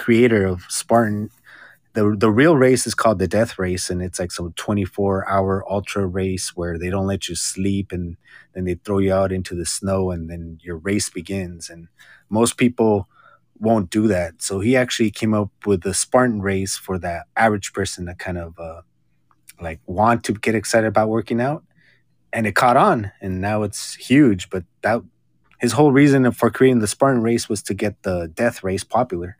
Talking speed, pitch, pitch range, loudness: 200 wpm, 100 Hz, 90-115 Hz, -20 LUFS